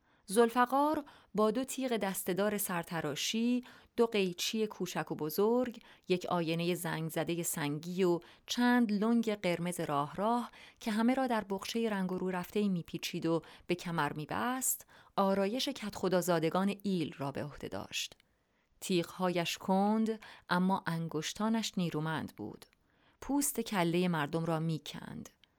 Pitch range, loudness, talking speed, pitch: 170-225 Hz, -34 LUFS, 135 wpm, 185 Hz